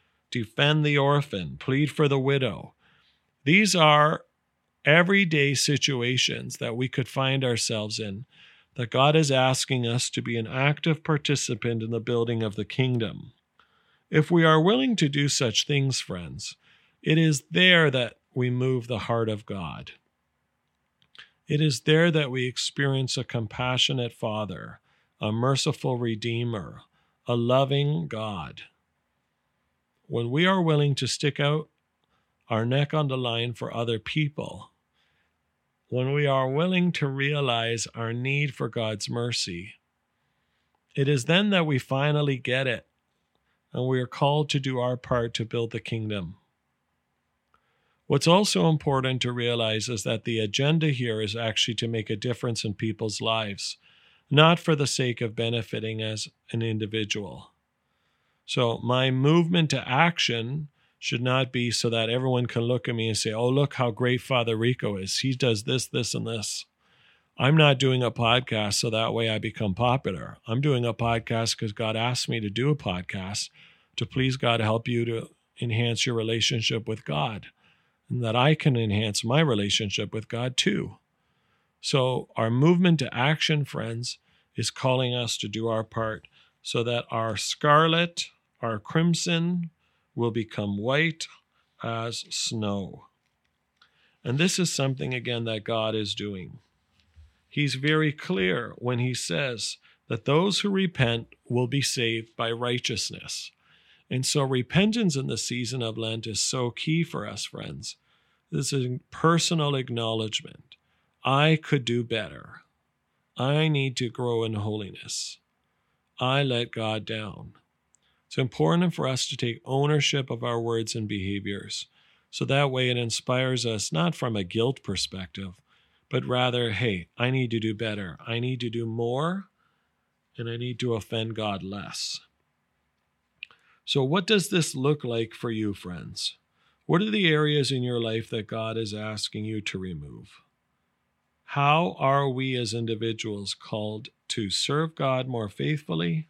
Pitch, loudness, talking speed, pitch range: 125 Hz, -26 LUFS, 155 wpm, 115-145 Hz